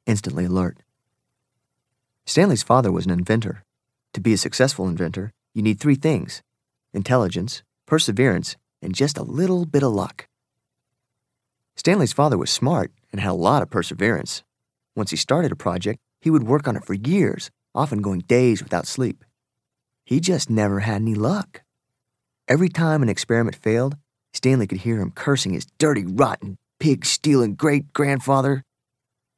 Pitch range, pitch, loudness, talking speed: 100-140 Hz, 120 Hz, -21 LUFS, 155 wpm